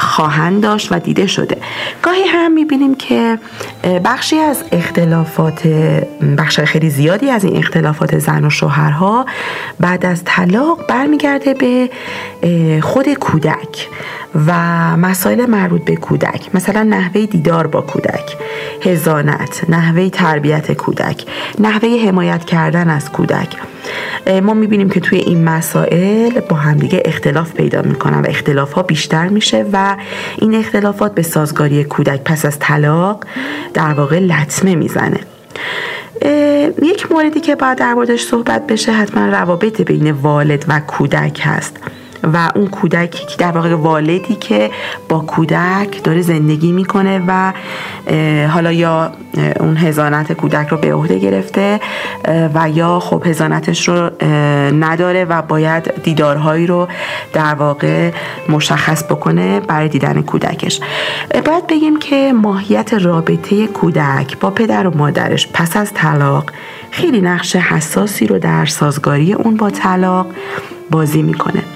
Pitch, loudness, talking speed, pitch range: 175 Hz, -13 LUFS, 130 wpm, 155-210 Hz